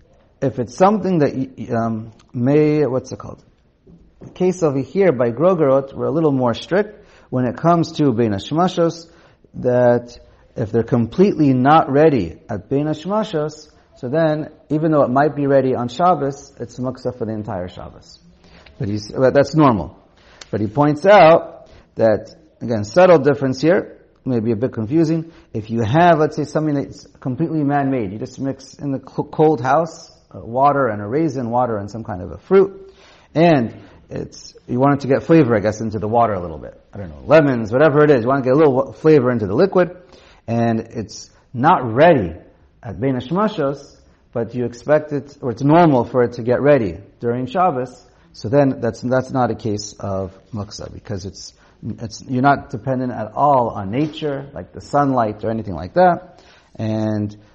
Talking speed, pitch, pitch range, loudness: 190 wpm, 130 Hz, 110-150 Hz, -17 LUFS